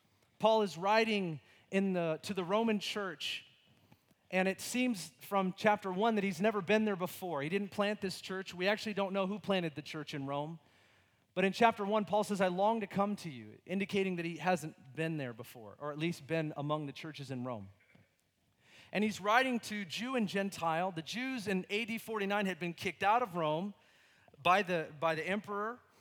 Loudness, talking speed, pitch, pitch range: -35 LUFS, 200 wpm, 190 Hz, 155-205 Hz